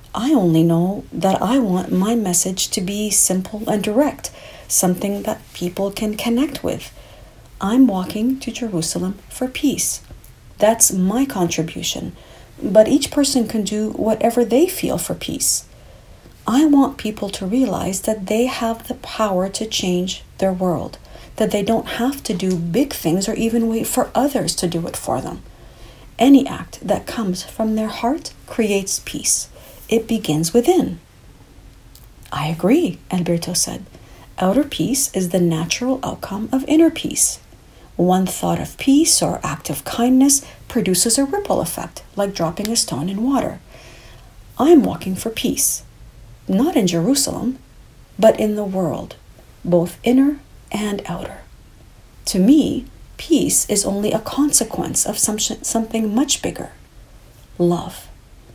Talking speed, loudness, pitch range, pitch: 145 wpm, -18 LUFS, 185-255 Hz, 215 Hz